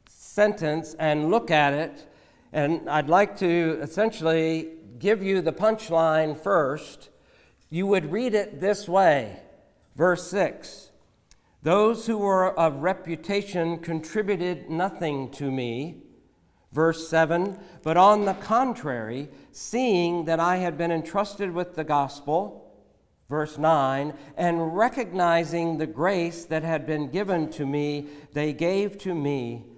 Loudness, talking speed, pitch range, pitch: -25 LUFS, 125 wpm, 155-190 Hz, 165 Hz